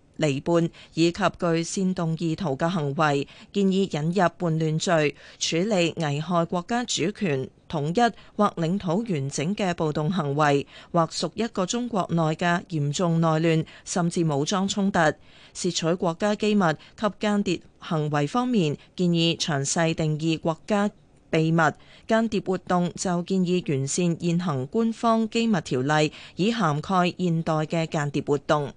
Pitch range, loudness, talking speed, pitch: 155-195 Hz, -25 LUFS, 225 characters per minute, 170 Hz